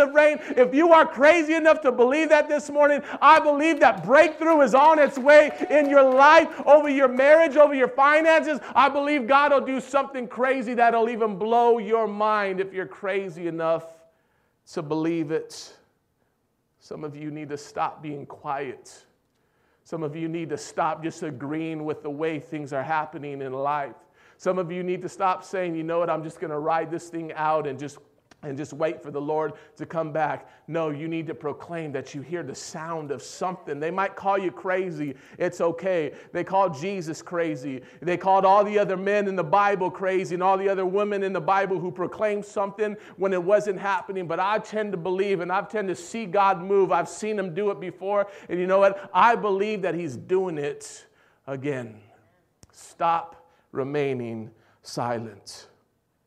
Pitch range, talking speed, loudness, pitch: 160-225 Hz, 195 wpm, -23 LUFS, 185 Hz